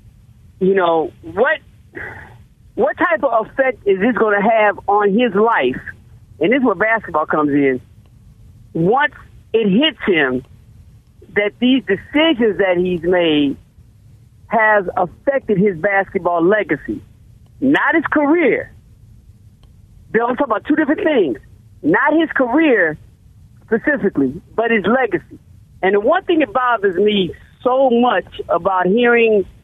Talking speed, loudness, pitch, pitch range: 130 wpm, -16 LUFS, 205 Hz, 170-255 Hz